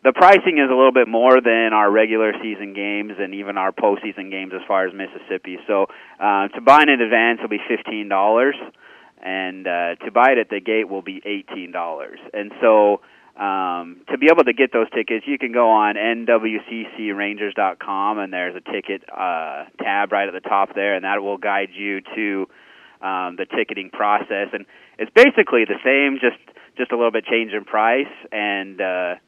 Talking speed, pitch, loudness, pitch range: 195 wpm, 105 Hz, -18 LUFS, 95-115 Hz